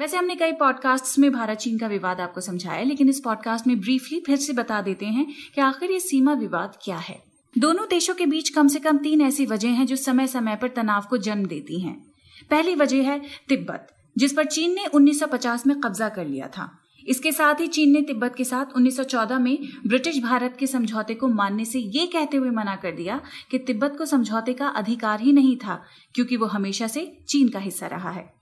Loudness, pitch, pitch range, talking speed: -23 LUFS, 260 Hz, 225-290 Hz, 220 wpm